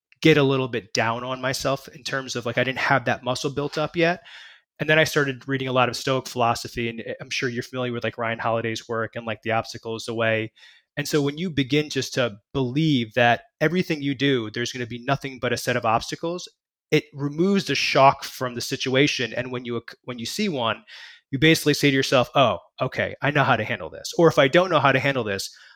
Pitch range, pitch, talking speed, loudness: 120-145 Hz, 130 Hz, 240 wpm, -23 LUFS